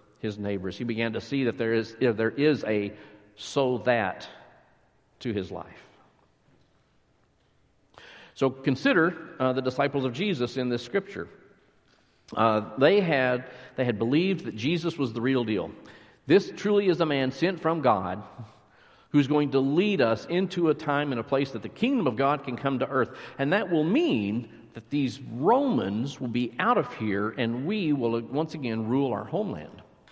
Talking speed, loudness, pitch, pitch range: 175 wpm, -27 LUFS, 130 Hz, 115-145 Hz